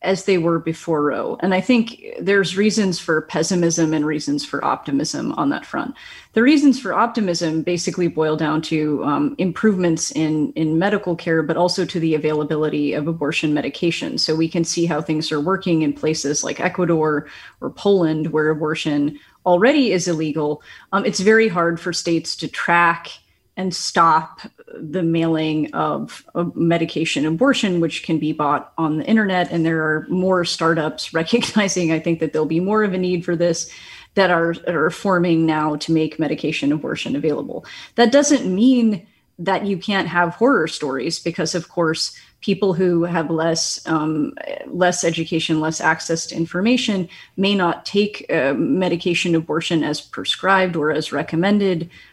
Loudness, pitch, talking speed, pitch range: -19 LUFS, 170 Hz, 165 wpm, 155-185 Hz